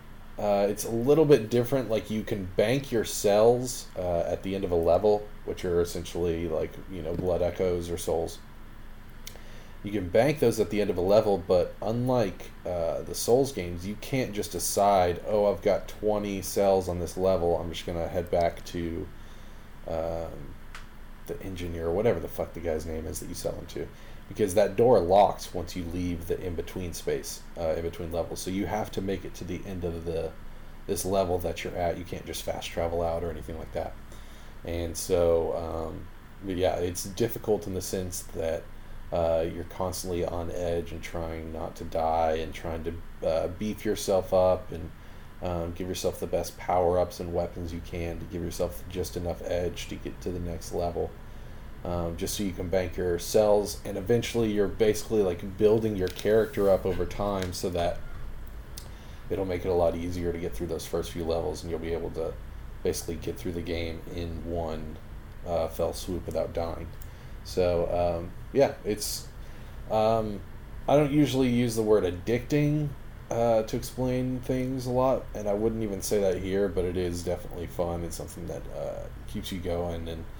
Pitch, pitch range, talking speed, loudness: 90 Hz, 85-105 Hz, 195 wpm, -29 LUFS